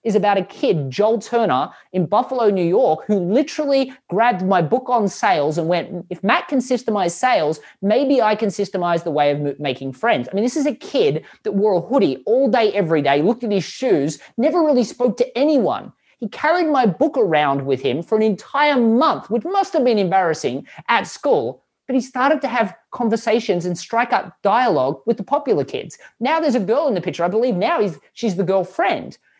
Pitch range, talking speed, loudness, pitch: 180-255 Hz, 210 wpm, -19 LUFS, 220 Hz